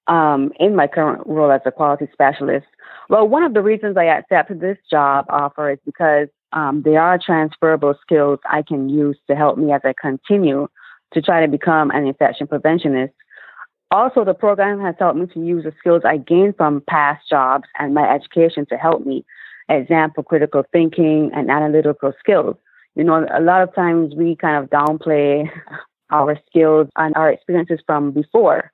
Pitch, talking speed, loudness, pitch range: 155 Hz, 180 wpm, -16 LUFS, 145-170 Hz